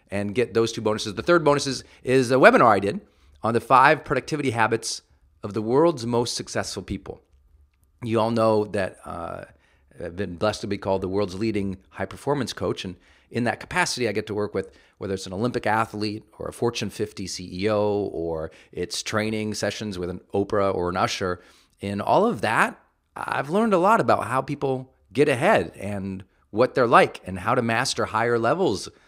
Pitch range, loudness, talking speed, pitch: 95-115 Hz, -23 LUFS, 195 wpm, 105 Hz